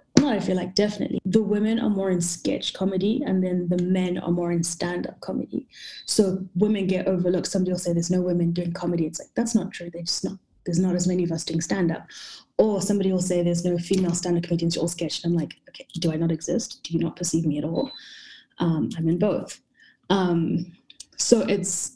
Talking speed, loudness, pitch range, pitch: 220 wpm, -24 LUFS, 170-195 Hz, 180 Hz